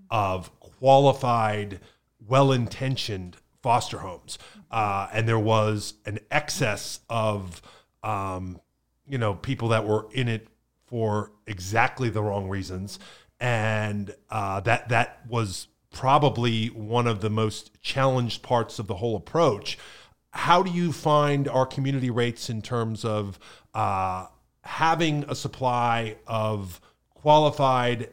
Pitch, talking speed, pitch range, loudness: 115 Hz, 125 wpm, 105-130 Hz, -25 LUFS